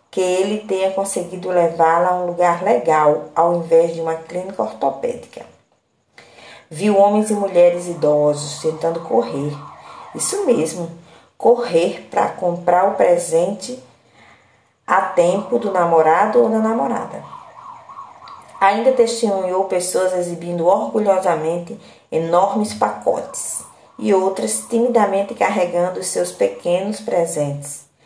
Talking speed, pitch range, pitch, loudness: 110 wpm, 165-205 Hz, 180 Hz, -18 LUFS